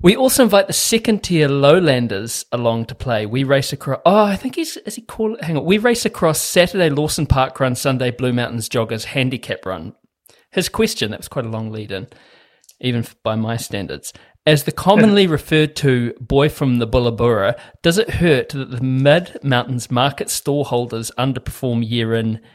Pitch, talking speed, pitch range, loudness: 135 Hz, 185 wpm, 120-170 Hz, -17 LUFS